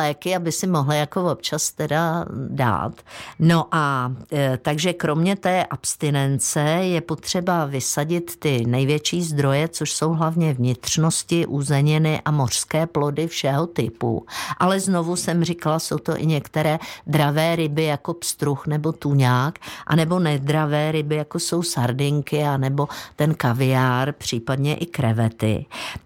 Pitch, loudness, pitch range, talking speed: 150 Hz, -21 LUFS, 140-165 Hz, 130 wpm